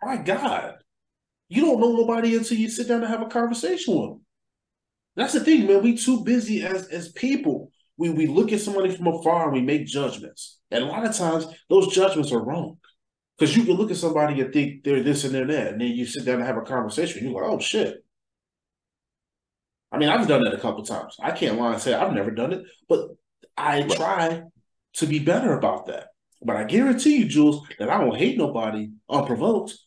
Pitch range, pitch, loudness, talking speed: 145-230 Hz, 180 Hz, -23 LUFS, 220 wpm